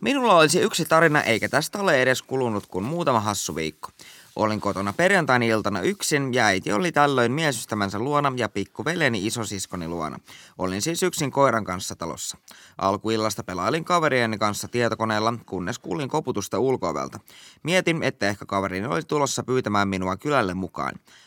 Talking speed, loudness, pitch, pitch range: 150 wpm, -23 LUFS, 115 Hz, 100-145 Hz